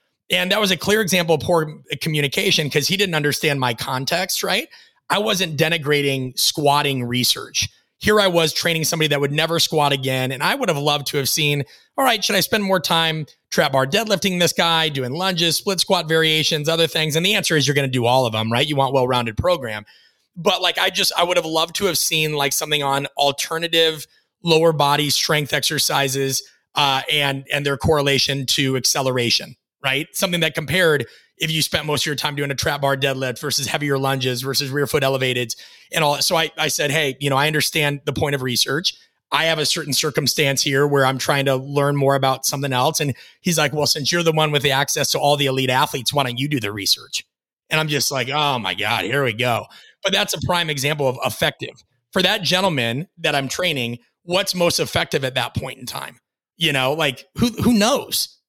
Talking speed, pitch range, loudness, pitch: 215 wpm, 135-165 Hz, -19 LUFS, 145 Hz